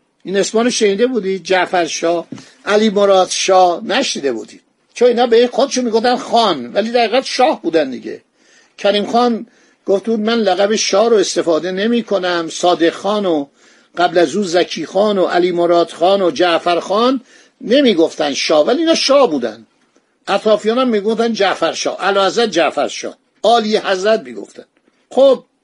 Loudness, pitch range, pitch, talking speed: -14 LUFS, 180-230 Hz, 200 Hz, 155 wpm